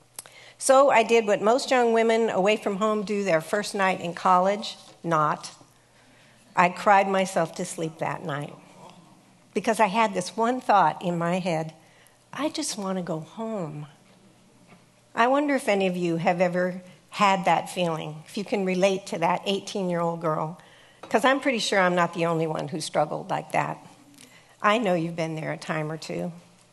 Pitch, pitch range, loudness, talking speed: 185 Hz, 160-210 Hz, -24 LUFS, 185 wpm